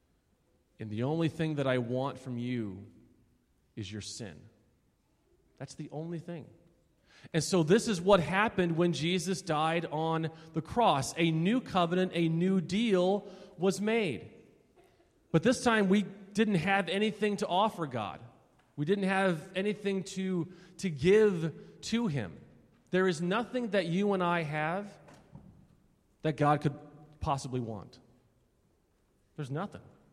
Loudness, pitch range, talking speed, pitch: -31 LUFS, 145-195 Hz, 140 wpm, 170 Hz